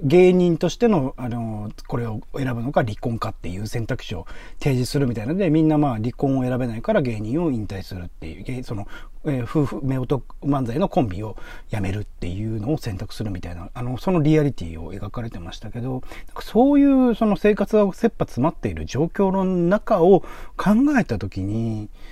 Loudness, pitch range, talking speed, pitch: -22 LUFS, 110-165 Hz, 375 characters per minute, 125 Hz